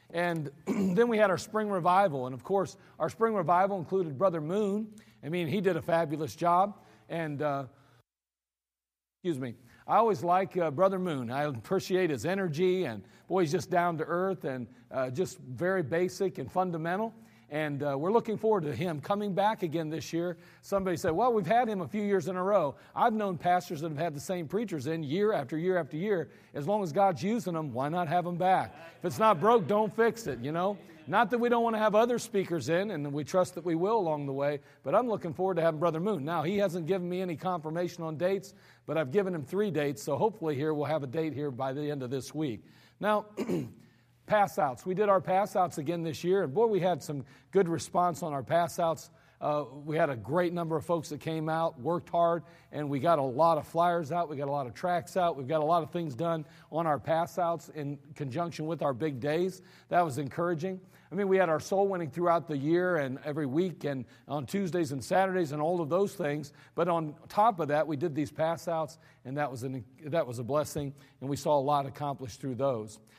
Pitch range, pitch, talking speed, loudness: 145-185 Hz, 170 Hz, 230 wpm, -30 LUFS